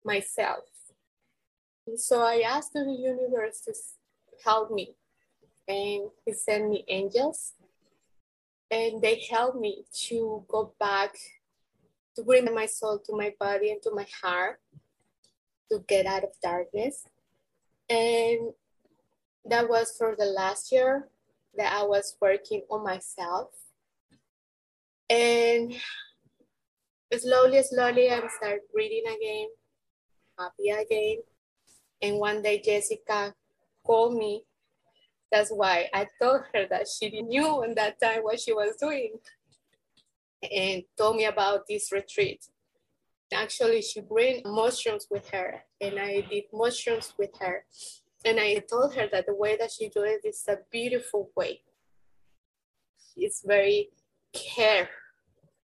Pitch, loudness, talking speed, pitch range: 225 Hz, -28 LUFS, 125 wpm, 205-275 Hz